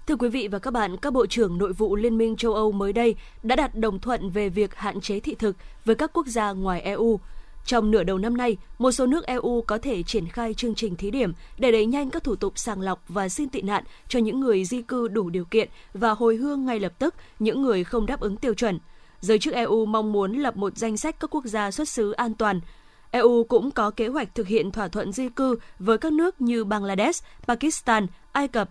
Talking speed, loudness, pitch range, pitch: 245 wpm, -25 LUFS, 205-245 Hz, 225 Hz